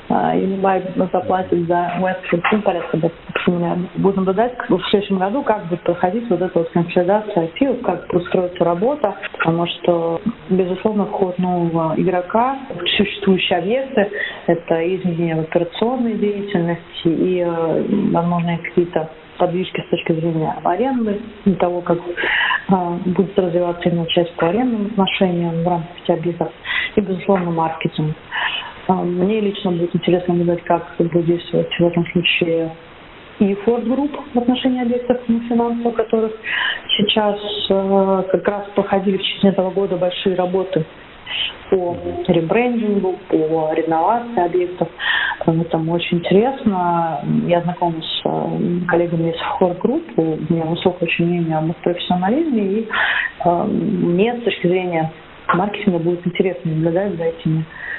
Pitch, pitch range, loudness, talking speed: 180 Hz, 170-205 Hz, -18 LUFS, 135 wpm